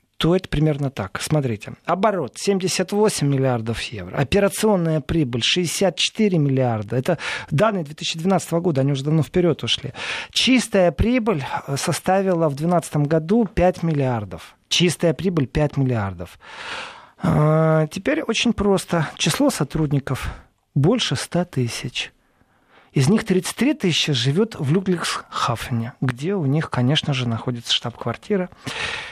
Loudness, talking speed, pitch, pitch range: -21 LUFS, 115 wpm, 160 Hz, 135-185 Hz